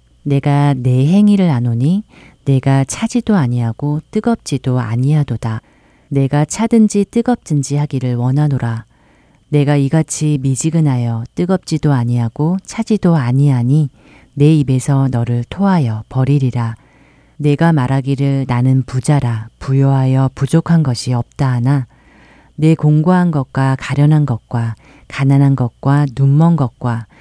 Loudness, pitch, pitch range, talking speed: -14 LUFS, 140 Hz, 125-150 Hz, 275 characters per minute